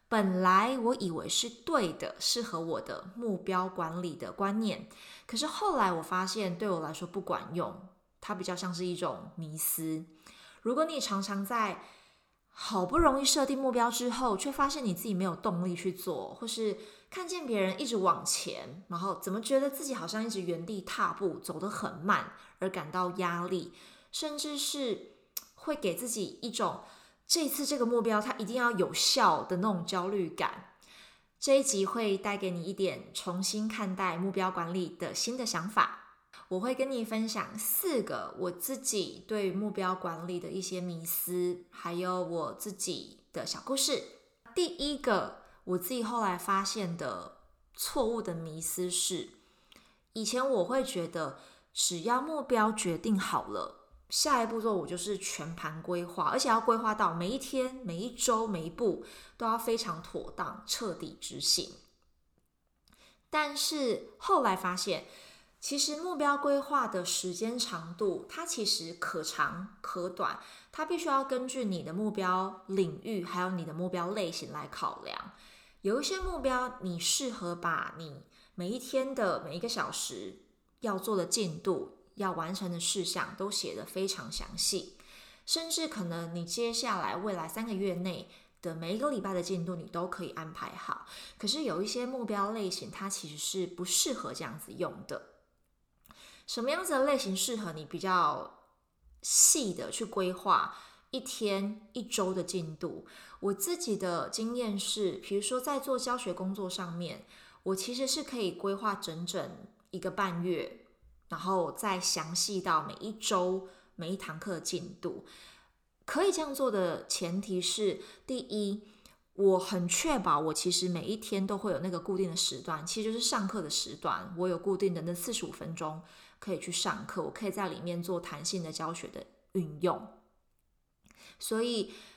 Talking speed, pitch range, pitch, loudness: 240 characters per minute, 180-235 Hz, 195 Hz, -33 LUFS